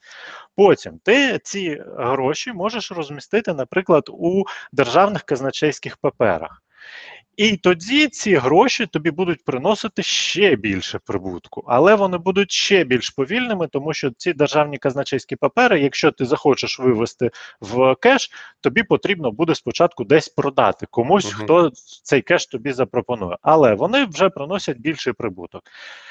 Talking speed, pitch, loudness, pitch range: 130 wpm, 160 Hz, -18 LUFS, 135-200 Hz